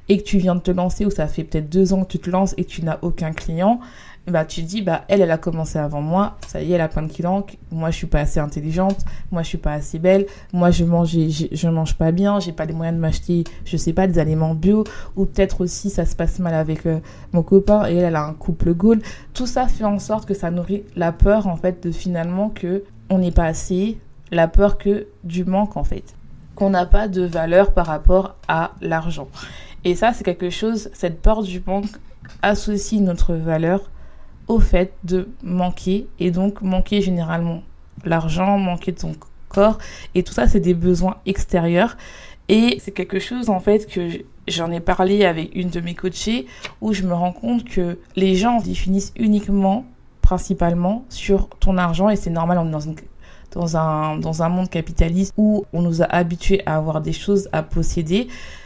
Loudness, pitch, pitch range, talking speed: -20 LUFS, 180 Hz, 165-200 Hz, 215 wpm